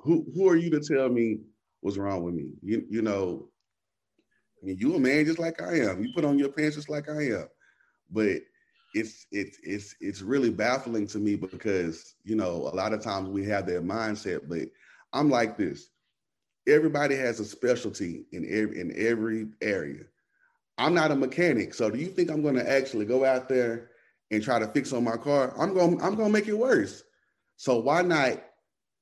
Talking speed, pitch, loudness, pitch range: 205 wpm, 130 Hz, -28 LUFS, 110-160 Hz